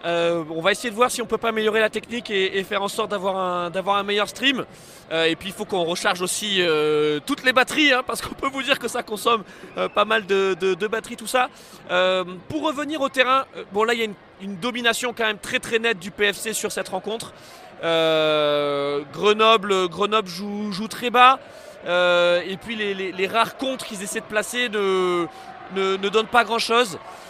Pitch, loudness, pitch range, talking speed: 210 Hz, -21 LUFS, 185-235 Hz, 225 wpm